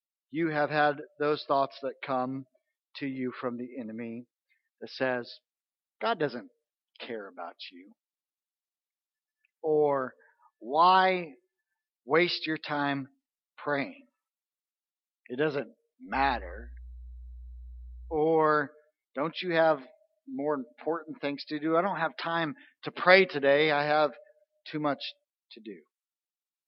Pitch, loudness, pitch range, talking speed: 150 Hz, -29 LUFS, 135-180 Hz, 110 wpm